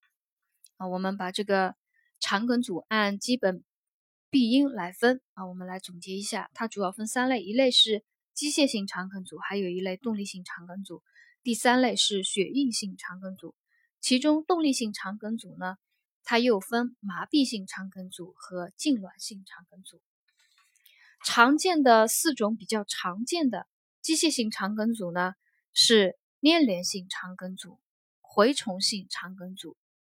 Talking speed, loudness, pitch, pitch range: 230 characters per minute, -26 LUFS, 210 Hz, 185-250 Hz